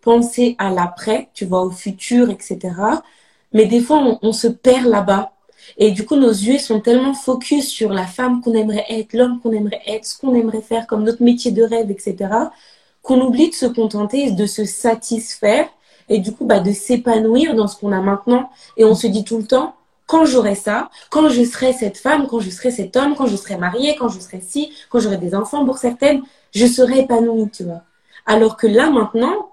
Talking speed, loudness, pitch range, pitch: 215 wpm, -16 LUFS, 210-255 Hz, 230 Hz